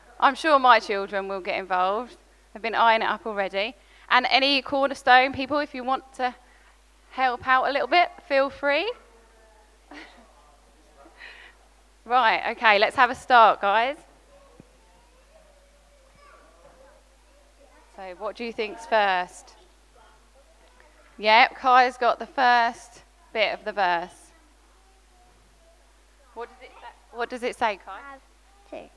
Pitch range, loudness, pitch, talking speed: 215-270 Hz, -22 LUFS, 245 Hz, 115 wpm